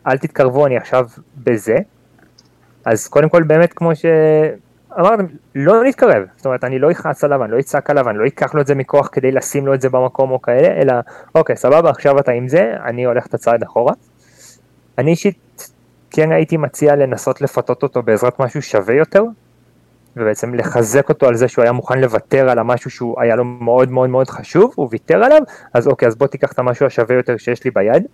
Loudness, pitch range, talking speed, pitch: -14 LUFS, 125-145 Hz, 205 wpm, 130 Hz